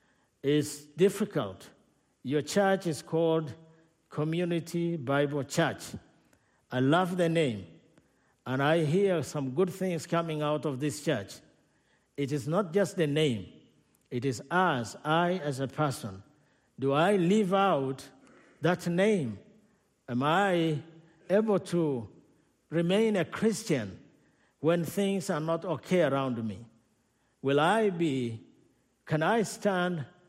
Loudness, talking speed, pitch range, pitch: -29 LUFS, 125 wpm, 135-180 Hz, 160 Hz